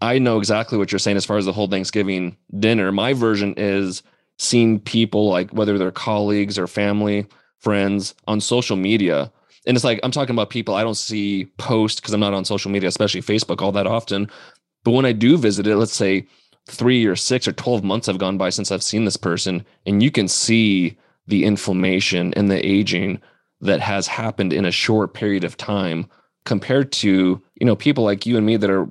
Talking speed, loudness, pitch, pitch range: 210 wpm, -19 LUFS, 105 Hz, 95-110 Hz